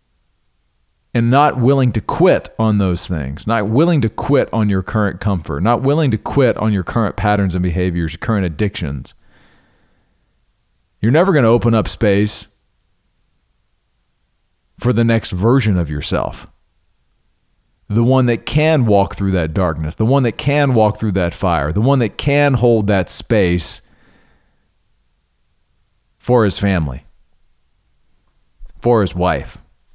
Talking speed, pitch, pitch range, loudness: 140 wpm, 105 Hz, 90-115 Hz, -16 LUFS